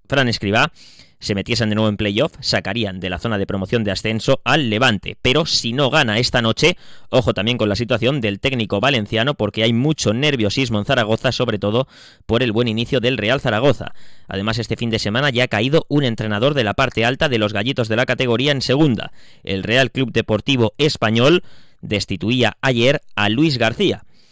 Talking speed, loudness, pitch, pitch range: 195 wpm, -18 LUFS, 115 Hz, 105-135 Hz